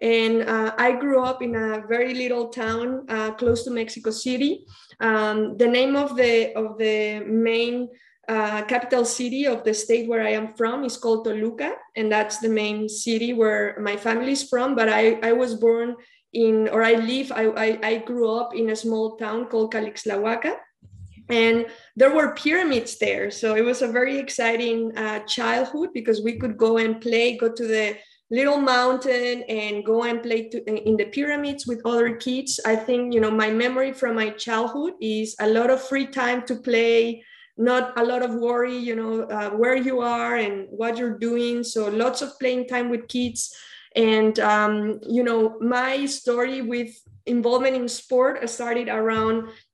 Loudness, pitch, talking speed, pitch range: -23 LUFS, 230 Hz, 185 wpm, 220-250 Hz